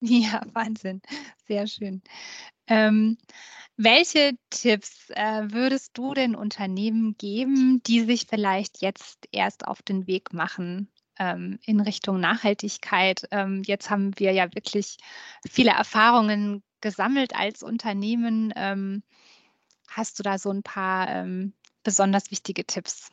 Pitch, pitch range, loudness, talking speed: 215 Hz, 195-235 Hz, -24 LUFS, 125 wpm